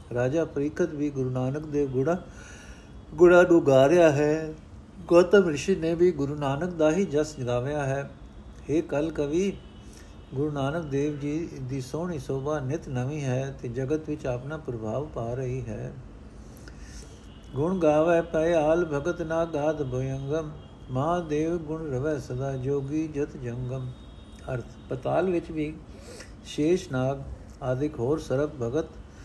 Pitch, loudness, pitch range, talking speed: 145 Hz, -26 LUFS, 130-160 Hz, 140 wpm